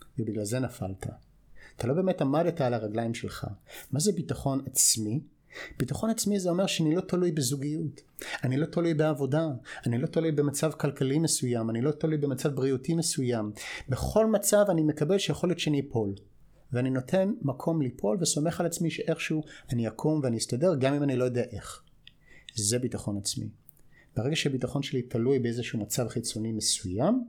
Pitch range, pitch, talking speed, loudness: 120-160 Hz, 140 Hz, 165 wpm, -29 LUFS